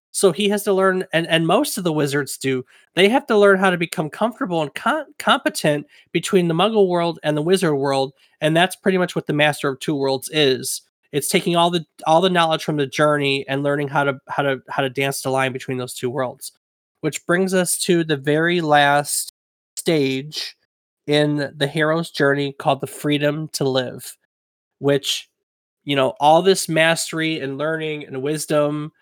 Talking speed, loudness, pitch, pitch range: 195 wpm, -19 LUFS, 155 Hz, 140-175 Hz